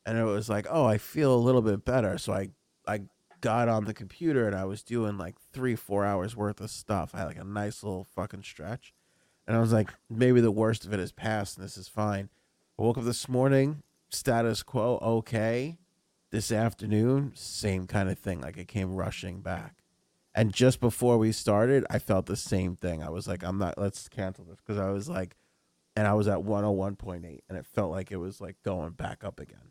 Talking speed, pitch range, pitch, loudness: 220 wpm, 95-115 Hz, 105 Hz, -29 LUFS